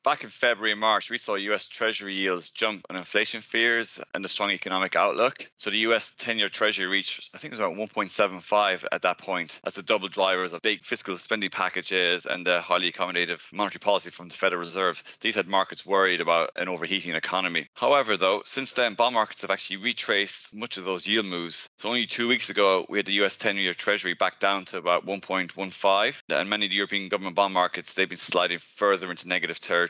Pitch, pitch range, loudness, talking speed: 95 Hz, 90-105 Hz, -25 LUFS, 215 wpm